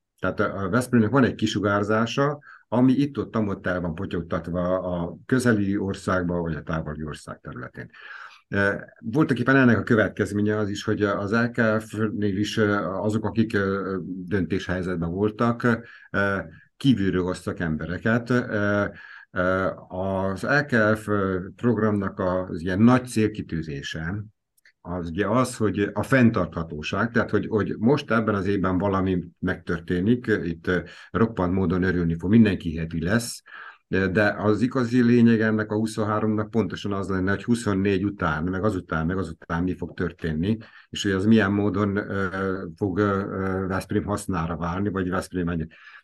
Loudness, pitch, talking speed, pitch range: -24 LUFS, 100 Hz, 135 wpm, 90-110 Hz